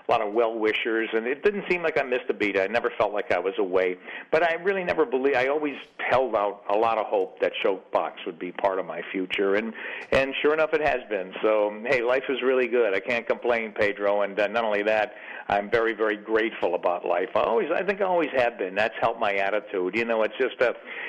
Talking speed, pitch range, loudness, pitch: 250 wpm, 105-145 Hz, -25 LUFS, 115 Hz